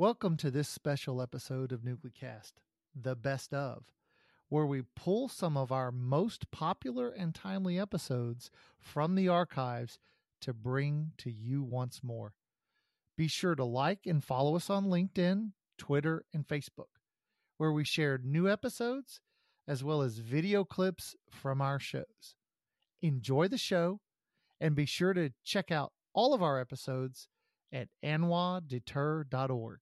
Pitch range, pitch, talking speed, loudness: 130-180 Hz, 150 Hz, 140 wpm, -35 LUFS